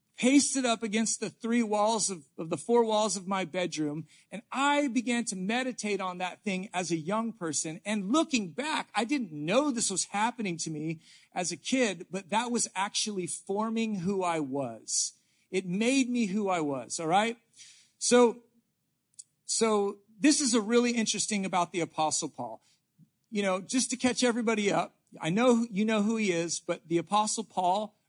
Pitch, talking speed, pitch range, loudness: 210 Hz, 180 wpm, 180-235 Hz, -29 LUFS